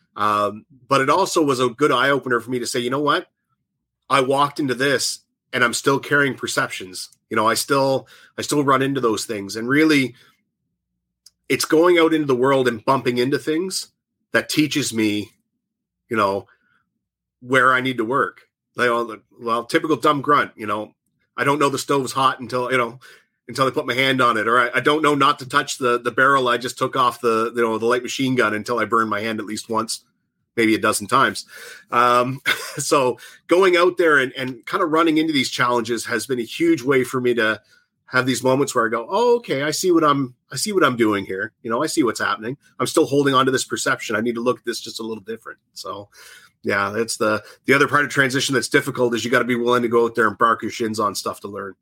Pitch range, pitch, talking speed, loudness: 115-145 Hz, 130 Hz, 235 wpm, -19 LUFS